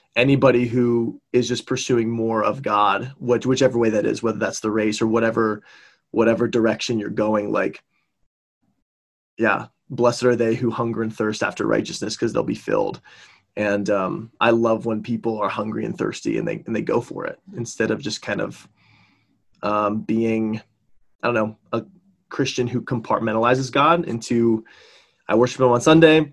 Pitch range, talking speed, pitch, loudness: 110-125 Hz, 175 wpm, 115 Hz, -21 LUFS